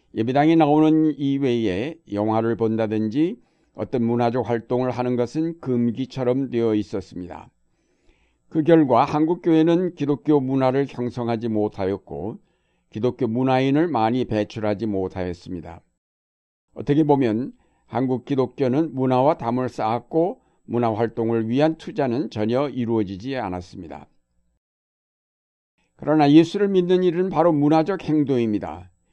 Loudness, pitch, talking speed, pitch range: -21 LUFS, 125 Hz, 295 characters per minute, 110-150 Hz